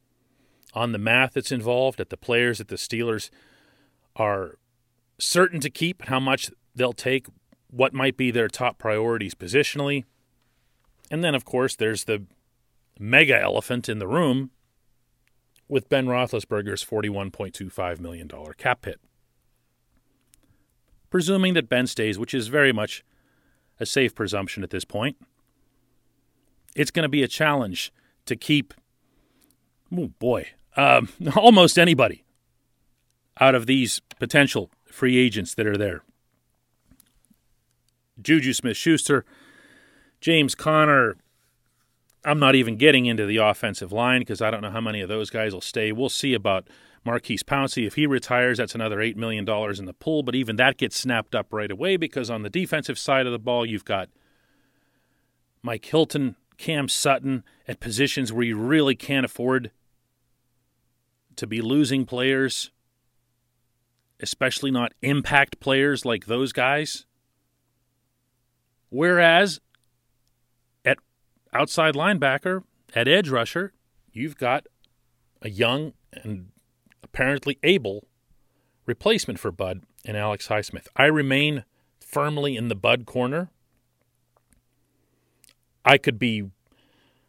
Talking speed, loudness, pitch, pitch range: 130 wpm, -22 LUFS, 125 Hz, 115-140 Hz